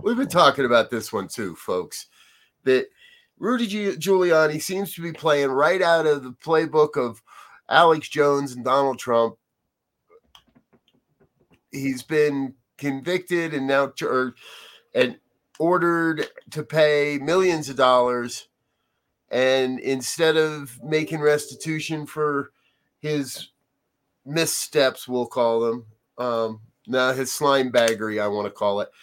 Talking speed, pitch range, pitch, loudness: 125 wpm, 130-165 Hz, 150 Hz, -22 LUFS